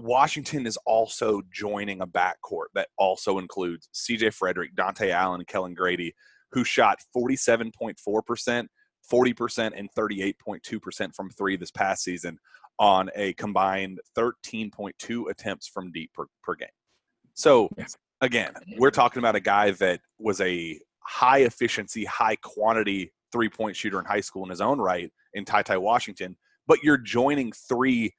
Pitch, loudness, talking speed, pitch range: 110 Hz, -26 LUFS, 145 wpm, 95-120 Hz